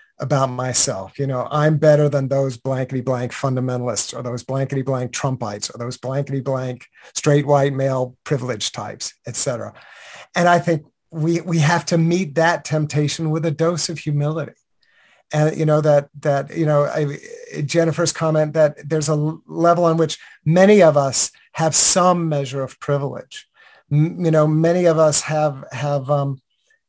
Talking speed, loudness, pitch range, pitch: 165 wpm, -19 LUFS, 135-165 Hz, 150 Hz